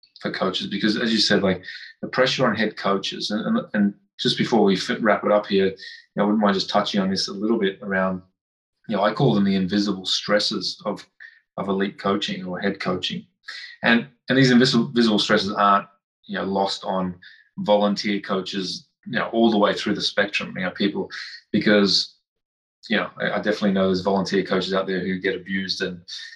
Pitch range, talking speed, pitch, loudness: 95-105 Hz, 205 wpm, 100 Hz, -22 LUFS